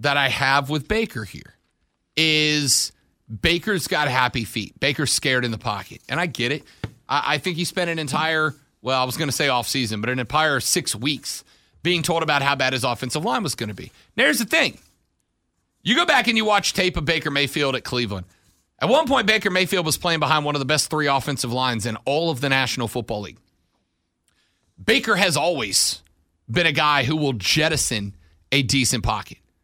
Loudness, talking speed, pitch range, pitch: -21 LUFS, 200 wpm, 120-155 Hz, 140 Hz